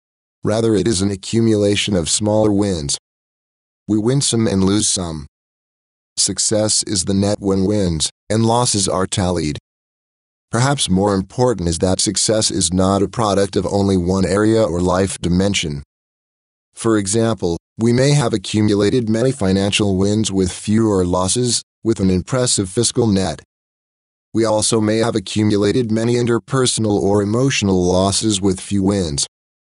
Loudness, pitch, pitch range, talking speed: -17 LUFS, 100 Hz, 95-110 Hz, 145 wpm